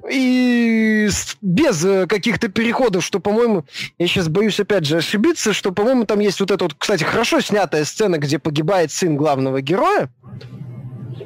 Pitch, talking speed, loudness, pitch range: 200 Hz, 150 wpm, -17 LUFS, 160-220 Hz